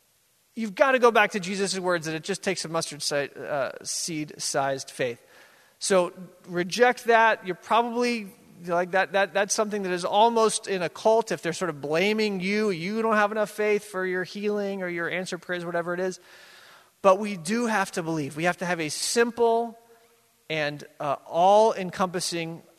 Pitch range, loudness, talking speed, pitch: 175-215 Hz, -25 LUFS, 175 wpm, 190 Hz